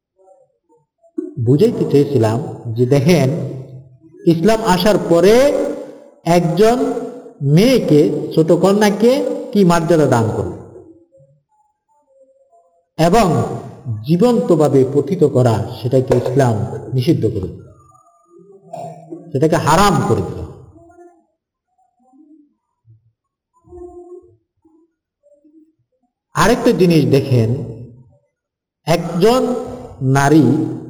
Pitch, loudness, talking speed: 170 Hz, -14 LUFS, 55 wpm